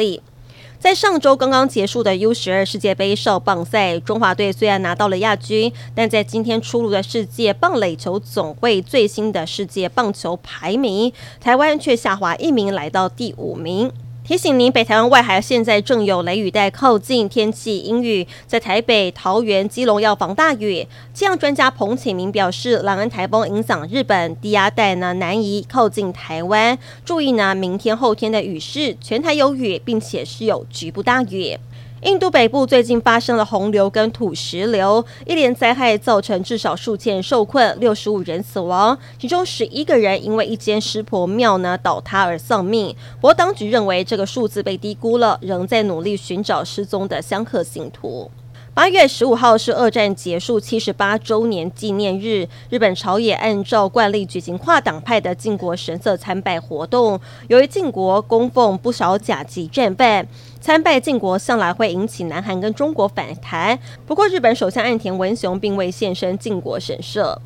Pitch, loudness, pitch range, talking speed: 210 Hz, -17 LUFS, 185-235 Hz, 270 characters per minute